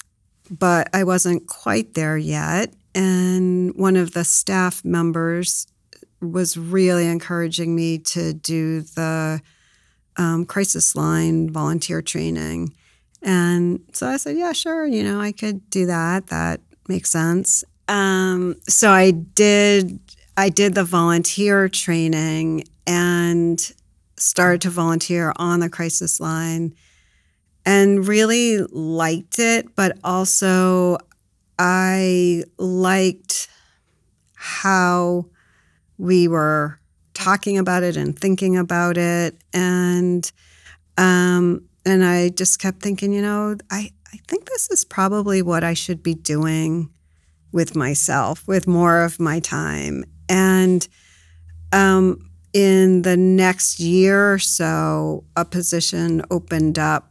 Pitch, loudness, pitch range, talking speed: 175 Hz, -18 LUFS, 160-190 Hz, 120 wpm